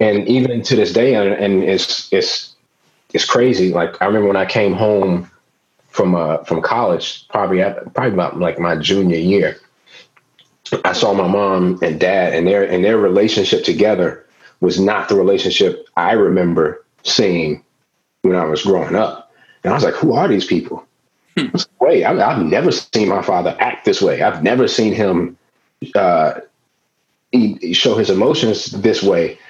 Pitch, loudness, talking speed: 120 Hz, -15 LUFS, 165 wpm